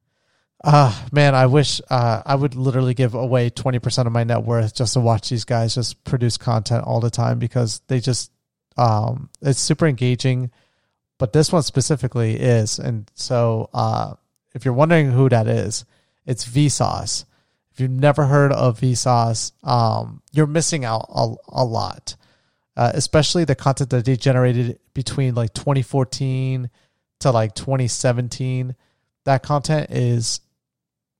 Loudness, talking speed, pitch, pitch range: -19 LUFS, 155 wpm, 125 Hz, 120-135 Hz